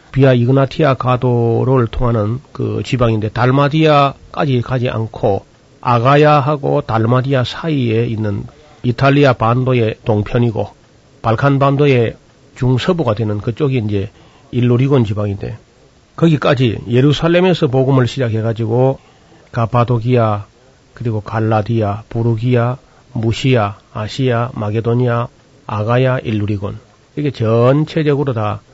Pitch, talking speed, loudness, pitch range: 125 Hz, 290 characters per minute, -15 LUFS, 115-135 Hz